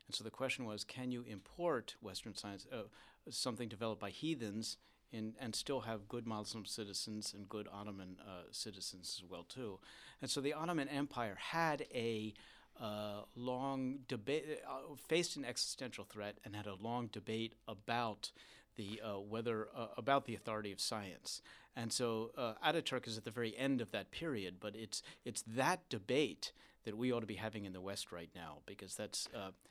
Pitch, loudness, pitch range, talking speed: 110 Hz, -43 LUFS, 105-125 Hz, 185 wpm